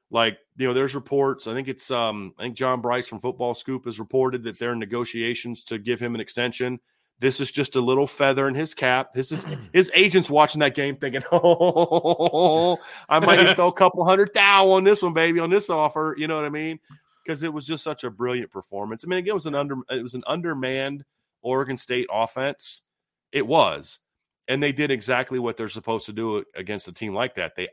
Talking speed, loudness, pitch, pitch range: 225 wpm, -22 LUFS, 135 Hz, 120-160 Hz